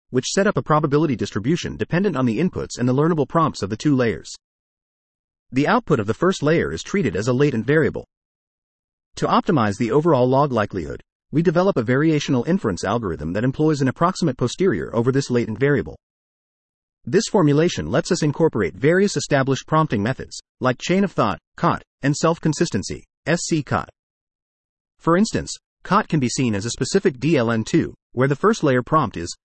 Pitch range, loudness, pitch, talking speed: 120-165 Hz, -20 LUFS, 145 Hz, 175 wpm